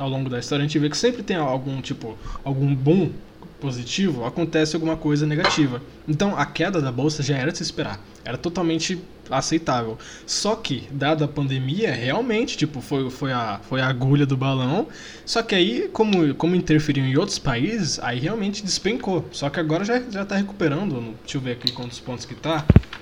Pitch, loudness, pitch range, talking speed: 150 Hz, -23 LUFS, 135-175 Hz, 195 wpm